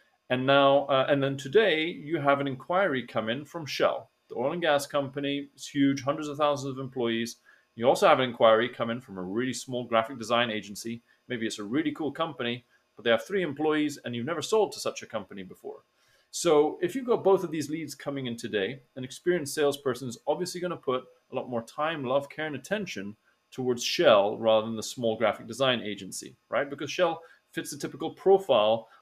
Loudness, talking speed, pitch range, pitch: -28 LUFS, 215 wpm, 120-155 Hz, 140 Hz